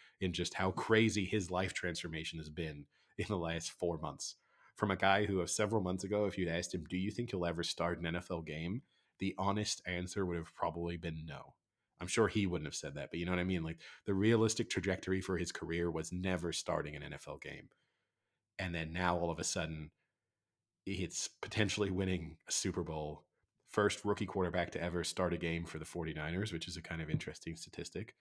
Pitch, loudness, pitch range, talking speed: 90 Hz, -38 LUFS, 85-95 Hz, 210 wpm